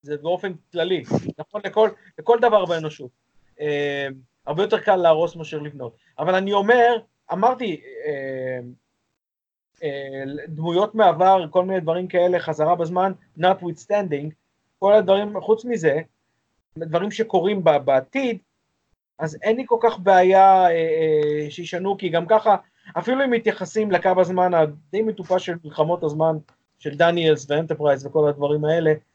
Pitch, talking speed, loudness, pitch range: 175 Hz, 140 wpm, -20 LUFS, 150-200 Hz